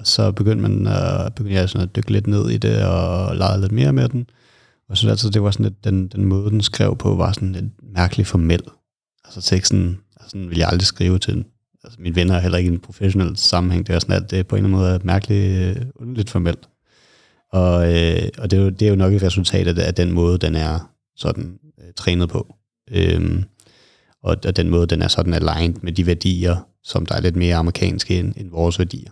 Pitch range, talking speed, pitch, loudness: 90-105 Hz, 235 wpm, 95 Hz, -19 LUFS